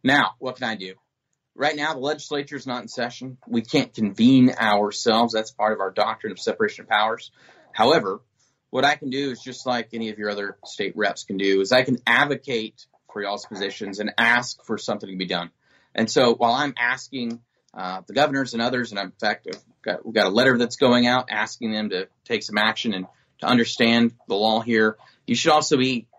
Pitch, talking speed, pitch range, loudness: 120 Hz, 220 wpm, 110-135 Hz, -22 LUFS